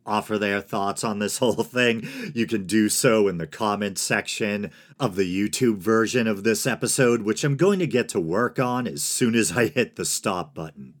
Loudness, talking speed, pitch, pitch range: -23 LUFS, 205 wpm, 110 Hz, 105-125 Hz